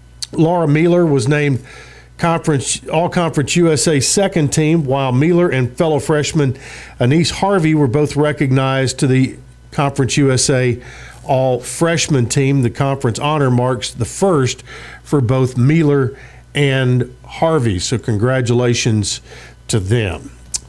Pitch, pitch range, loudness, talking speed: 135 Hz, 125-155 Hz, -15 LUFS, 120 wpm